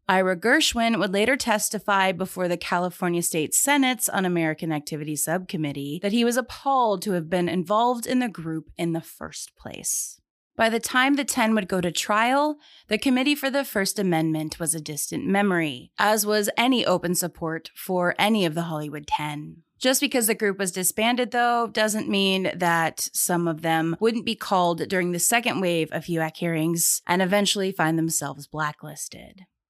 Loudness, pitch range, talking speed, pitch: -23 LUFS, 165-225 Hz, 175 wpm, 185 Hz